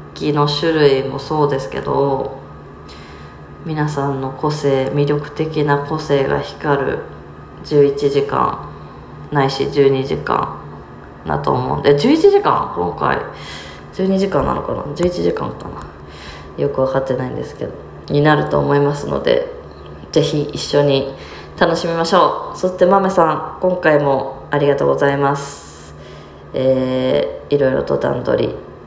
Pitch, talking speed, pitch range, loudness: 140 Hz, 245 characters per minute, 130-155 Hz, -17 LUFS